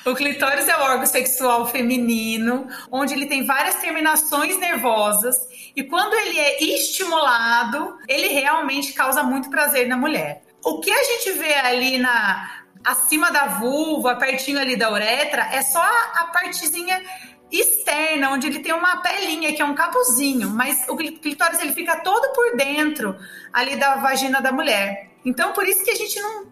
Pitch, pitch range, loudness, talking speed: 285 Hz, 255-335 Hz, -19 LUFS, 165 wpm